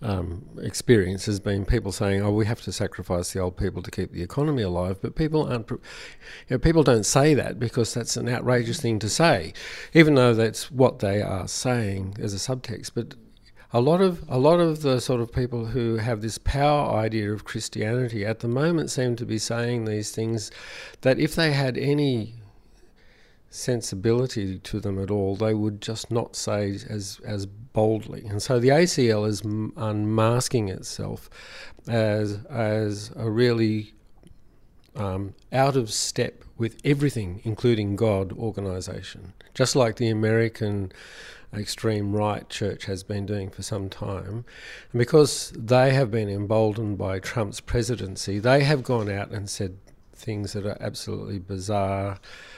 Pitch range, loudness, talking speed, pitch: 100-125 Hz, -25 LUFS, 170 wpm, 110 Hz